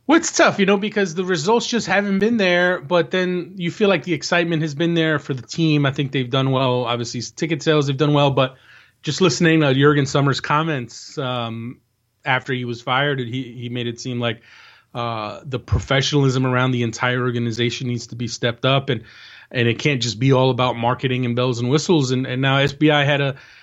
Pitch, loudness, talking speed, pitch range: 135 Hz, -19 LUFS, 215 wpm, 125-160 Hz